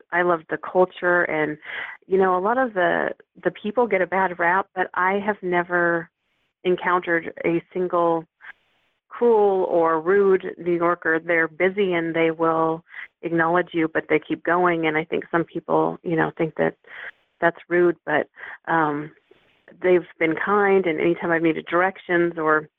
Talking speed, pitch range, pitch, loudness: 165 wpm, 165-185 Hz, 175 Hz, -22 LUFS